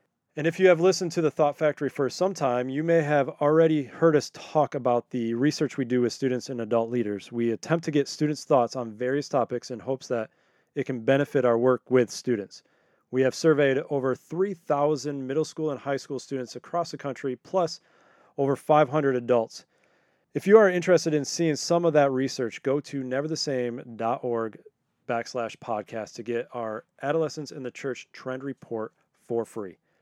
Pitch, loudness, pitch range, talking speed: 140 Hz, -26 LUFS, 125-155 Hz, 180 wpm